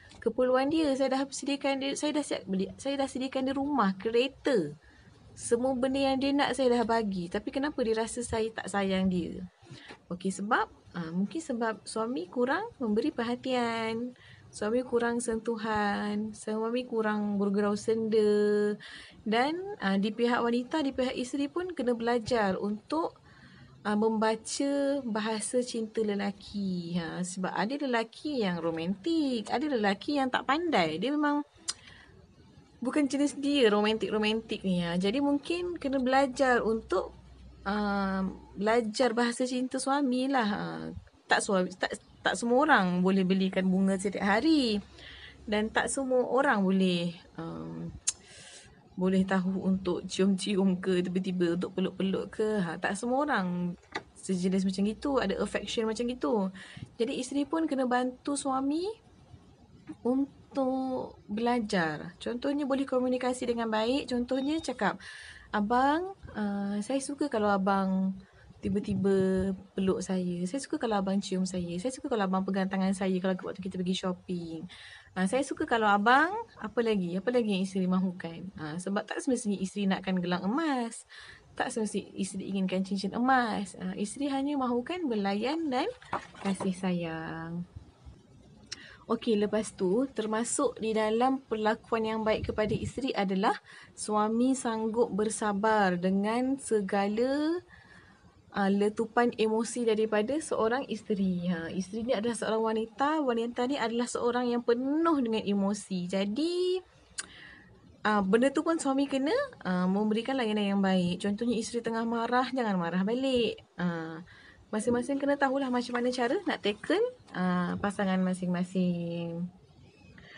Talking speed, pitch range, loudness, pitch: 135 wpm, 195-255 Hz, -30 LUFS, 220 Hz